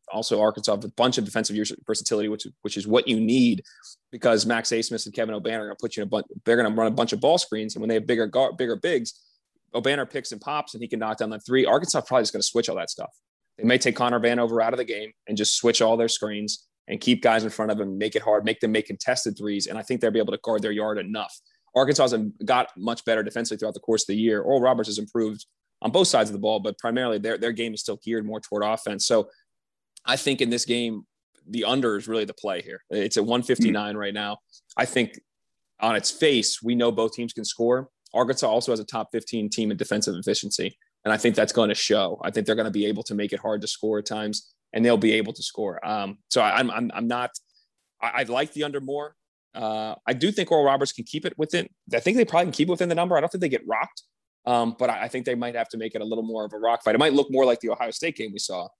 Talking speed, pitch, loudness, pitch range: 280 wpm, 115 Hz, -24 LUFS, 110-125 Hz